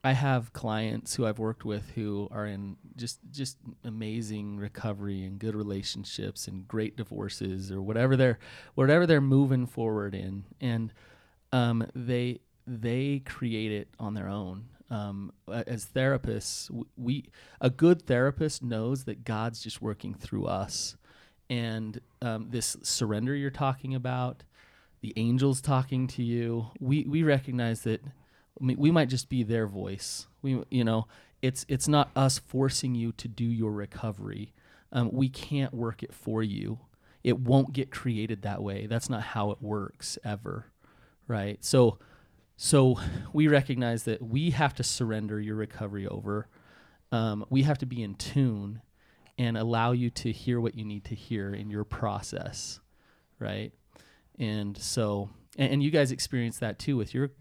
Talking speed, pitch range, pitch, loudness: 160 wpm, 105-130 Hz, 115 Hz, -30 LUFS